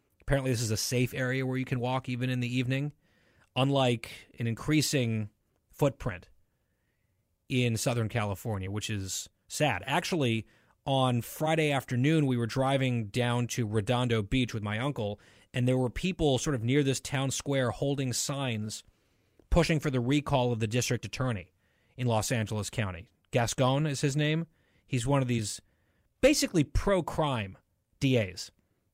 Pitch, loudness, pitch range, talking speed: 125 Hz, -30 LUFS, 110-135 Hz, 155 wpm